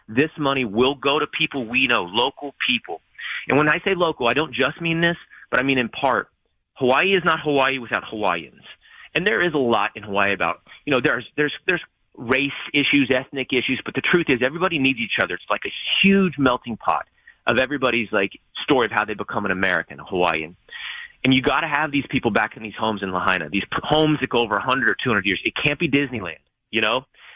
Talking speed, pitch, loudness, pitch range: 225 wpm, 130 Hz, -21 LUFS, 110-145 Hz